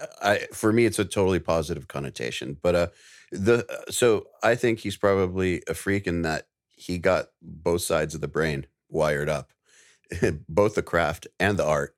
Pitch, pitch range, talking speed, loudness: 90 Hz, 80-105 Hz, 175 wpm, -25 LUFS